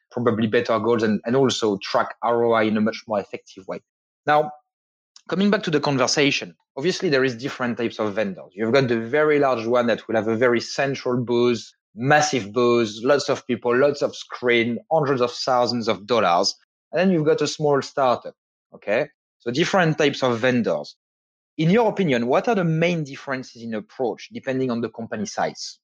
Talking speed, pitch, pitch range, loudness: 190 wpm, 125 Hz, 115-150 Hz, -22 LUFS